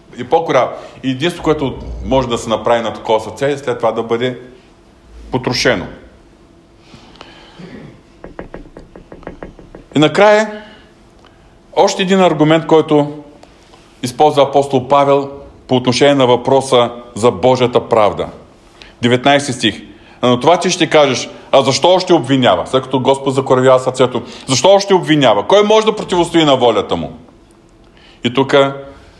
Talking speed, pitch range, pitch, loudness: 125 wpm, 125-160 Hz, 135 Hz, -13 LUFS